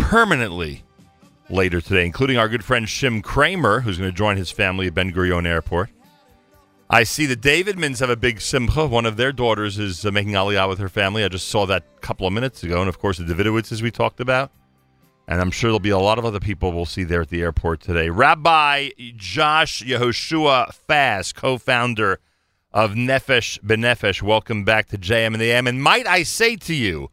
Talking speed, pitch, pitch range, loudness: 205 wpm, 110 Hz, 95-125 Hz, -19 LUFS